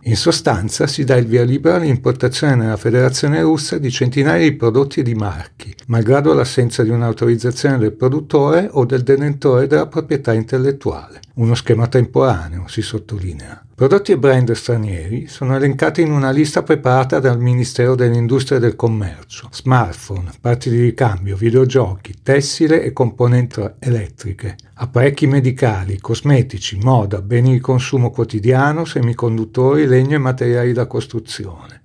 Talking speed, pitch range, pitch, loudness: 140 wpm, 115-140 Hz, 125 Hz, -15 LUFS